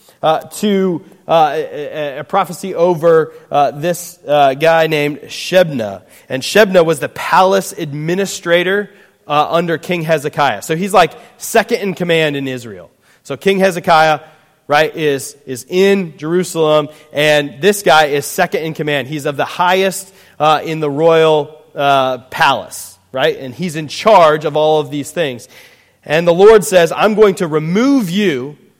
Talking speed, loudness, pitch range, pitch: 155 wpm, -13 LUFS, 150-185 Hz, 160 Hz